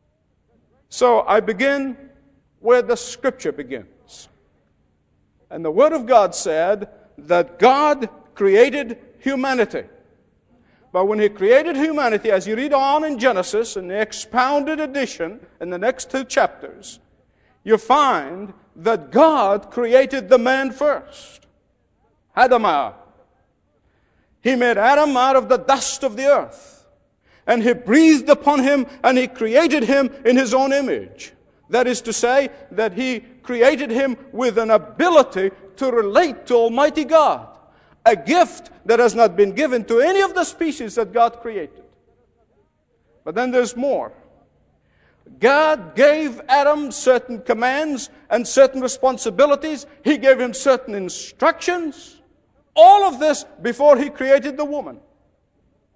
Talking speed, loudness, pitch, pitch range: 135 wpm, -17 LUFS, 260 Hz, 230-290 Hz